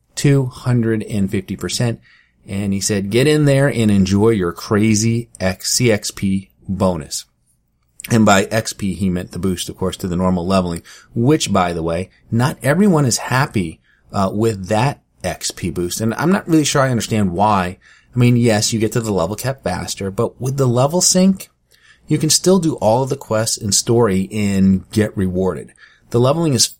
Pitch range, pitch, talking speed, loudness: 95-125 Hz, 110 Hz, 175 wpm, -17 LUFS